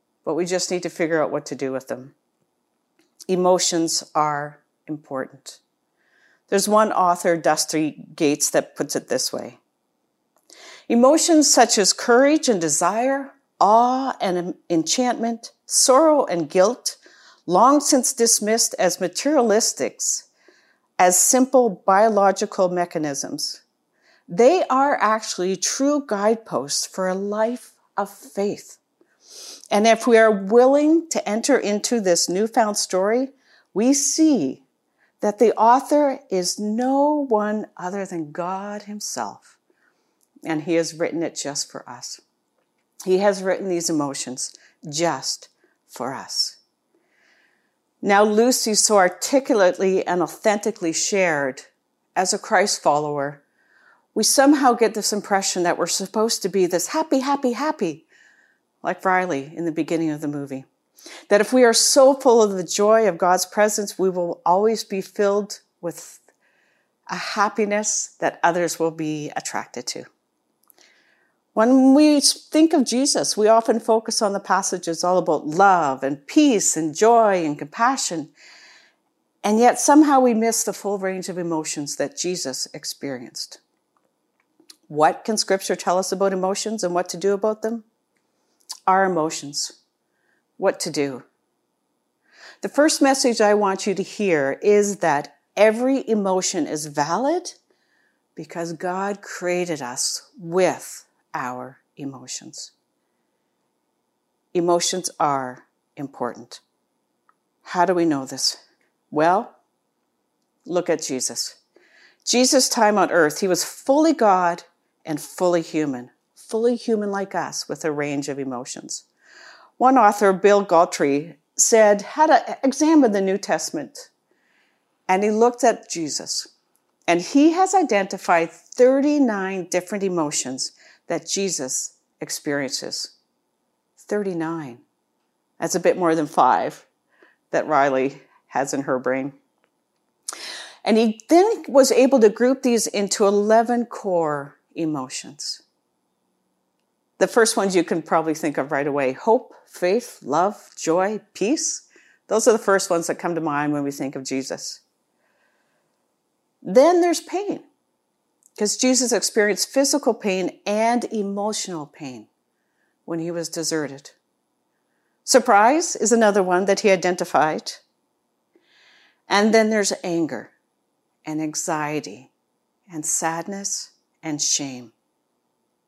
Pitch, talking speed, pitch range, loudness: 195 Hz, 125 wpm, 165-235 Hz, -20 LUFS